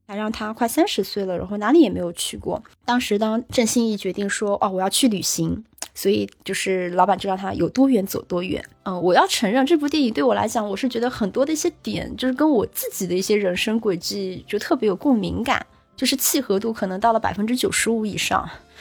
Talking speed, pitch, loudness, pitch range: 345 characters per minute, 215 Hz, -21 LUFS, 190-250 Hz